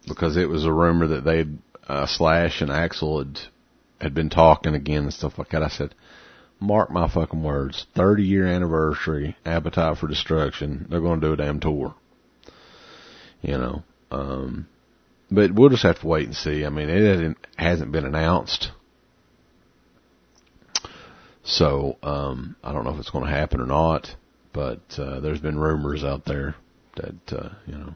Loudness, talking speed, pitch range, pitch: -23 LUFS, 170 wpm, 70-85 Hz, 80 Hz